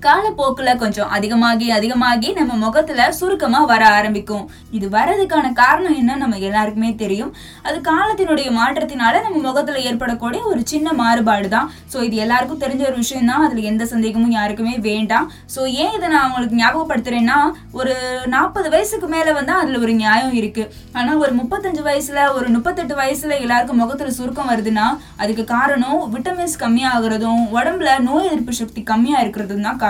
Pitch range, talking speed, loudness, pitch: 230-295 Hz, 150 wpm, -17 LUFS, 250 Hz